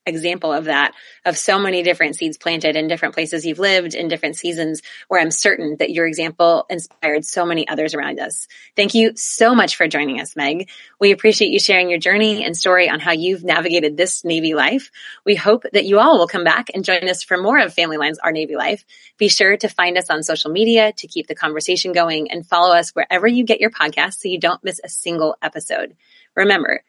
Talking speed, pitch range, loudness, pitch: 225 wpm, 165-200 Hz, -16 LUFS, 175 Hz